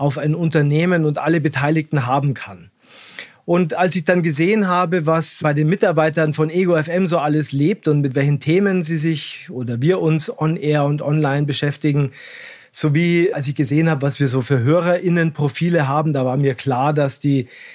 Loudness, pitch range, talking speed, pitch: -18 LUFS, 145-170 Hz, 190 wpm, 155 Hz